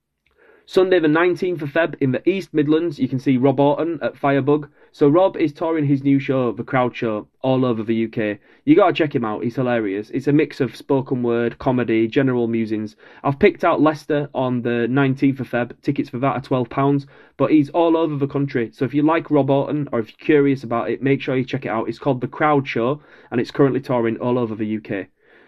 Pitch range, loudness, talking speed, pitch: 120-150 Hz, -20 LUFS, 230 wpm, 135 Hz